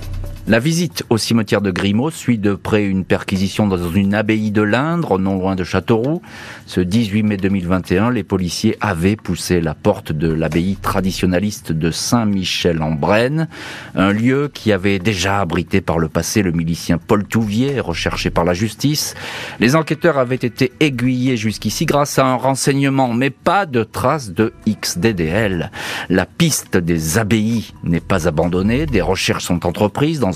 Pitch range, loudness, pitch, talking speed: 95-120 Hz, -17 LUFS, 105 Hz, 160 wpm